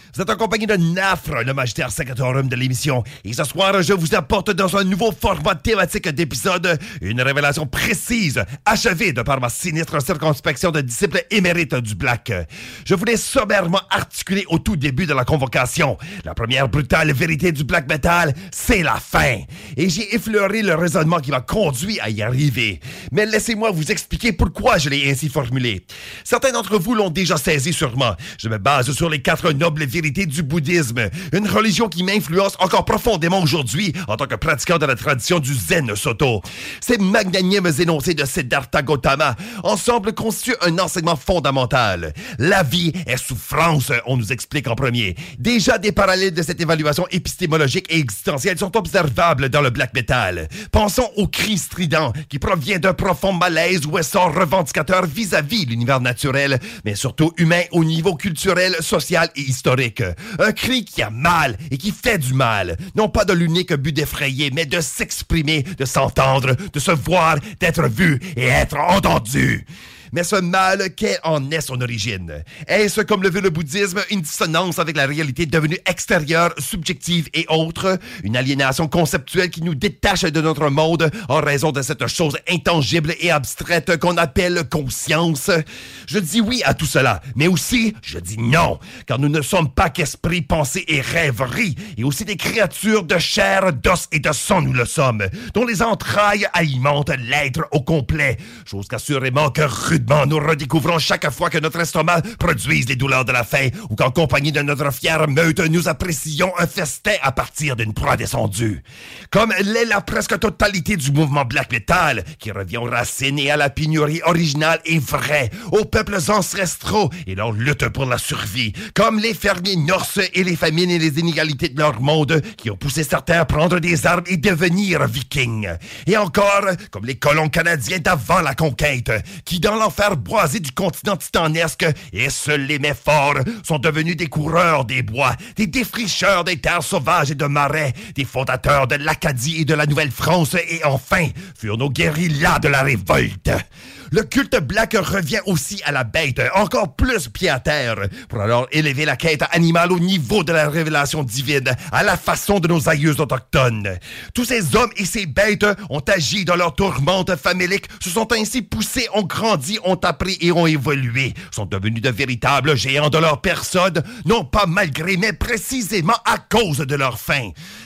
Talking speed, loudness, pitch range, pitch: 175 wpm, -18 LUFS, 140-185 Hz, 165 Hz